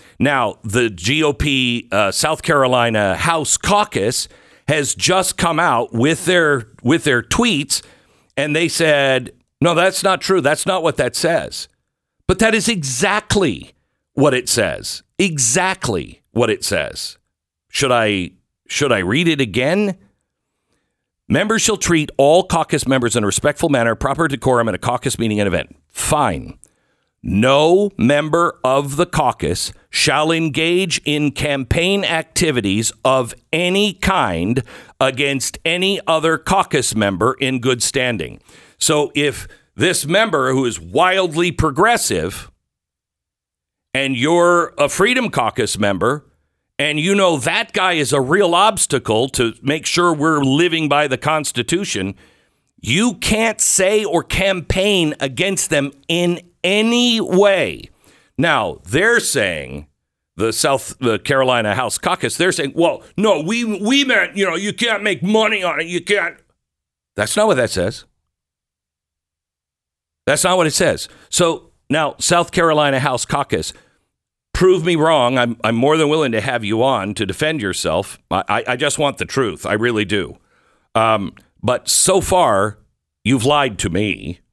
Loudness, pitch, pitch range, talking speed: -16 LUFS, 150 Hz, 120-175 Hz, 145 wpm